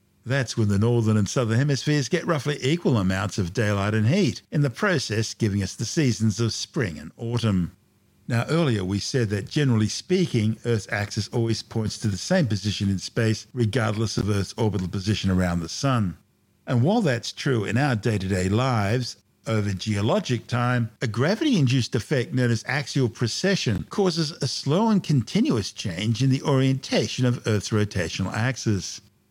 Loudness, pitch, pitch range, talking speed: -24 LUFS, 115 Hz, 105-130 Hz, 175 wpm